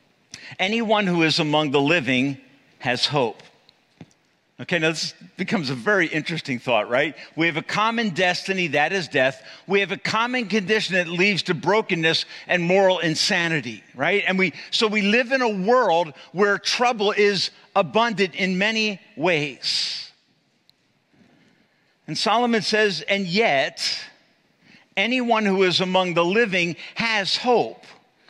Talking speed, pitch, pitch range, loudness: 140 wpm, 190 Hz, 165-215 Hz, -21 LUFS